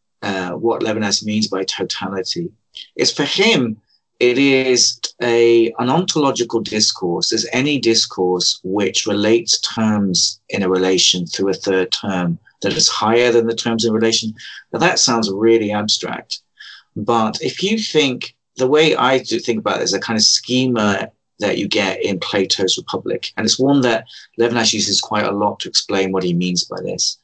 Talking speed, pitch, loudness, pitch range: 175 wpm, 115 Hz, -16 LUFS, 100-120 Hz